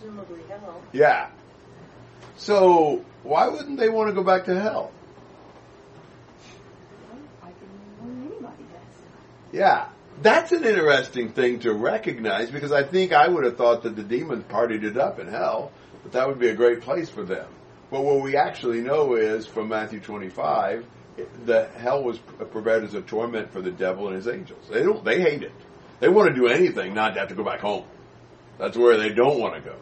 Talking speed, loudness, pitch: 175 wpm, -22 LUFS, 140 Hz